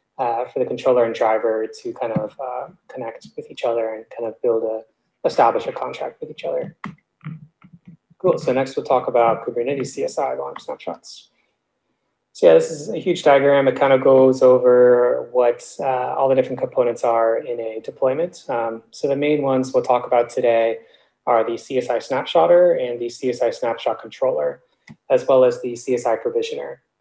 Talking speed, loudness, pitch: 180 wpm, -19 LUFS, 135 Hz